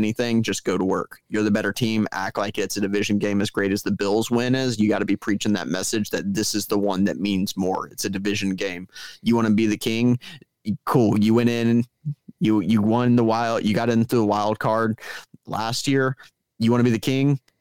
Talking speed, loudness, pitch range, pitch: 240 wpm, -22 LUFS, 105-120 Hz, 110 Hz